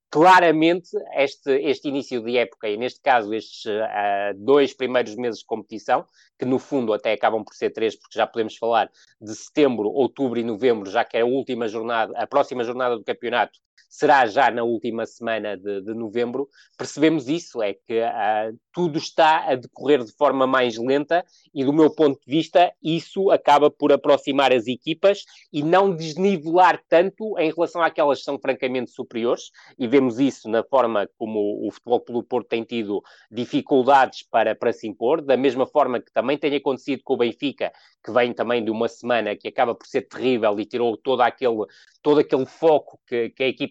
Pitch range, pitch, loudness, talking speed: 115-155 Hz, 130 Hz, -22 LUFS, 190 wpm